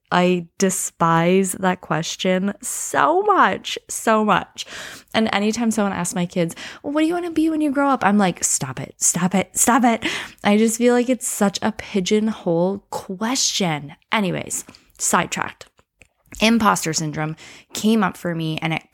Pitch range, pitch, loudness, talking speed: 175-235 Hz, 200 Hz, -20 LUFS, 165 wpm